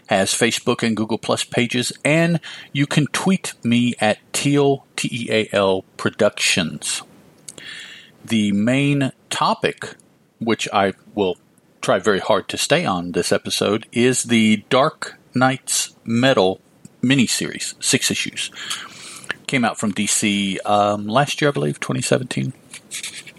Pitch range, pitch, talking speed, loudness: 105-130 Hz, 115 Hz, 120 wpm, -19 LUFS